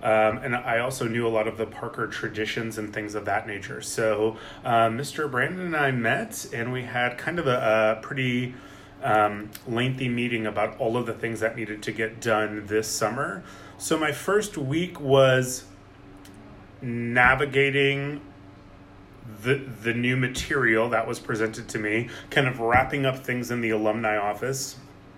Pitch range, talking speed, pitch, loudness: 110-130 Hz, 165 wpm, 115 Hz, -25 LUFS